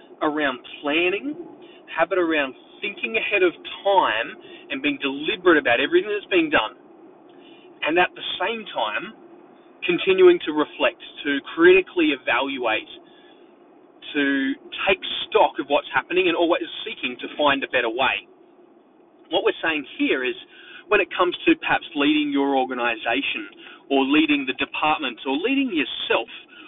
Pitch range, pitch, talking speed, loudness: 280-355 Hz, 345 Hz, 140 wpm, -22 LUFS